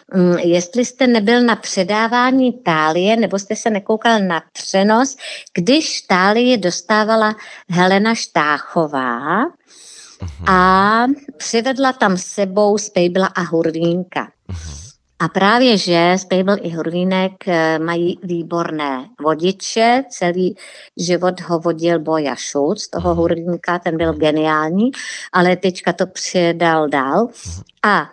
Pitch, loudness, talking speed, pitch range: 185 Hz, -16 LUFS, 105 wpm, 170-220 Hz